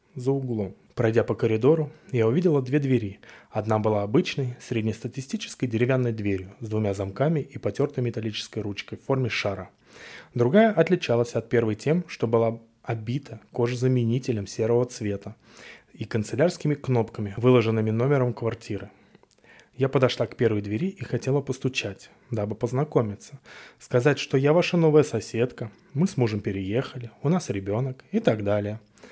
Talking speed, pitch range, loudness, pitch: 140 wpm, 110-135 Hz, -25 LUFS, 120 Hz